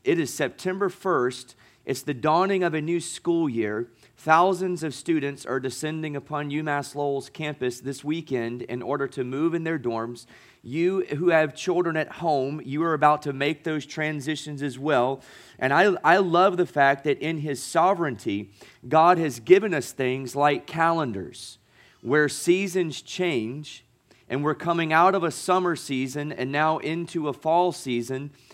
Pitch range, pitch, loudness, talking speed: 135-165 Hz, 150 Hz, -24 LUFS, 165 wpm